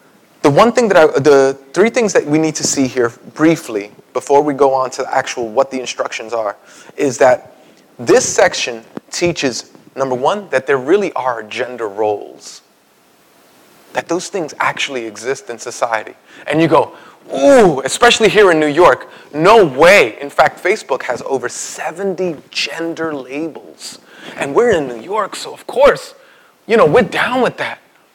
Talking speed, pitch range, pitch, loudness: 165 wpm, 130-175 Hz, 145 Hz, -14 LUFS